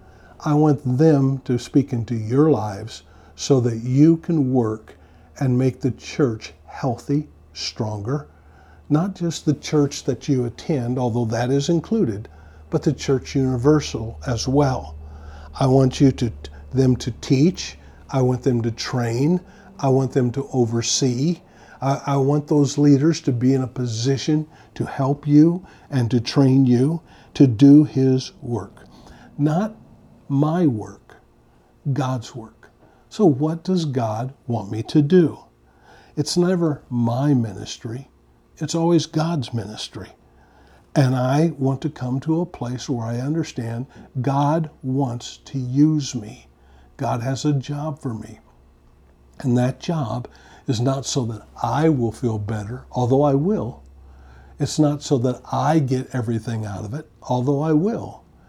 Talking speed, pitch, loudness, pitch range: 145 wpm, 130 Hz, -21 LUFS, 115-145 Hz